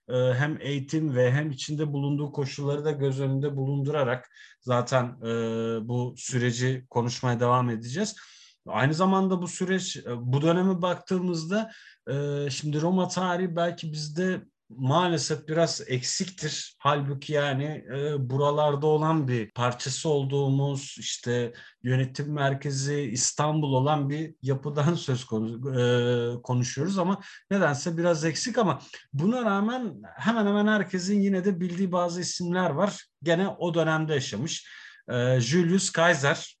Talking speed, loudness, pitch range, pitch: 120 wpm, -27 LUFS, 130-175 Hz, 145 Hz